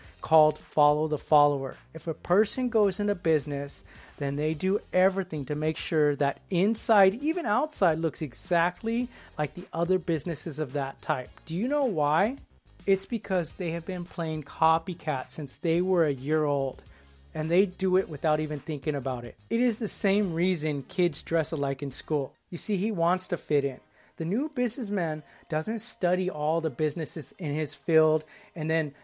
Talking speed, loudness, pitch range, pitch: 180 wpm, -28 LUFS, 150-185 Hz, 160 Hz